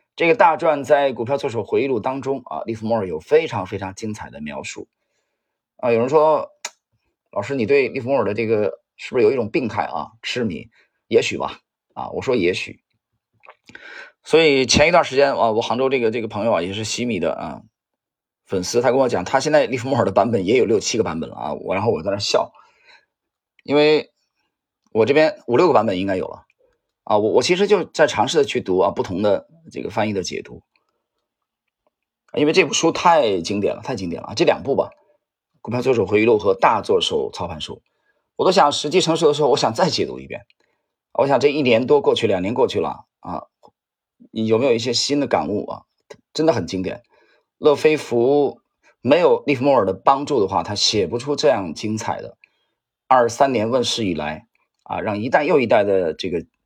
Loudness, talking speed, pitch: -19 LUFS, 290 characters per minute, 150 Hz